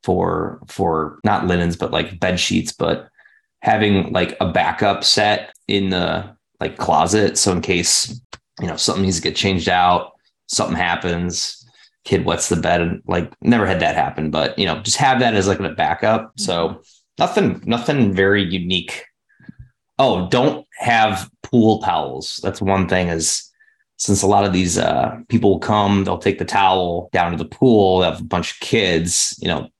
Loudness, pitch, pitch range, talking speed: -18 LUFS, 95 Hz, 90-100 Hz, 180 wpm